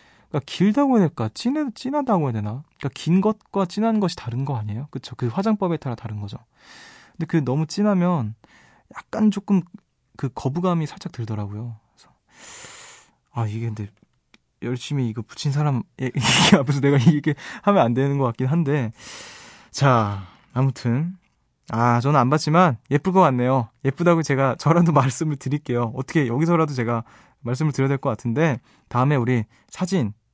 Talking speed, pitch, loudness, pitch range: 330 characters per minute, 140 Hz, -22 LUFS, 120-170 Hz